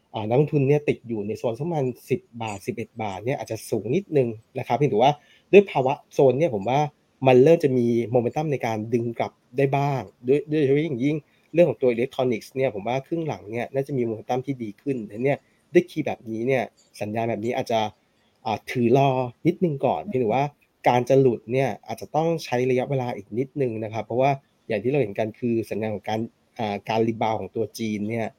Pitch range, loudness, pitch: 110-140 Hz, -24 LUFS, 125 Hz